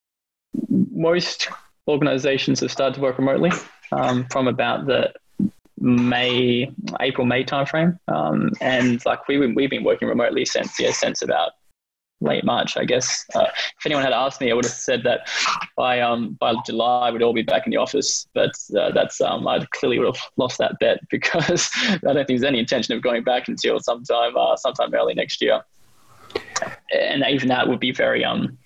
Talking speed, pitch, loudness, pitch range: 185 wpm, 125 Hz, -21 LUFS, 120-140 Hz